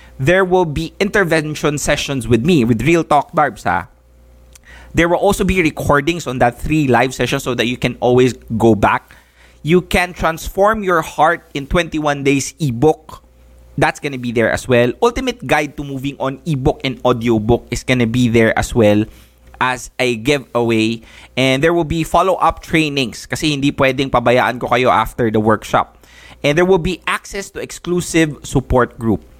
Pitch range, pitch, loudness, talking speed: 120-160 Hz, 140 Hz, -16 LUFS, 170 wpm